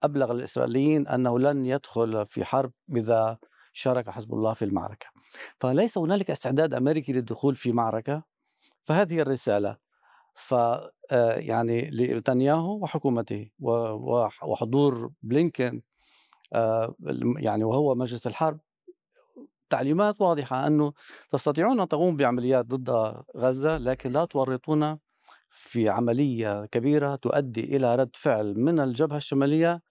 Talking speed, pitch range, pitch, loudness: 110 wpm, 115-150 Hz, 130 Hz, -26 LUFS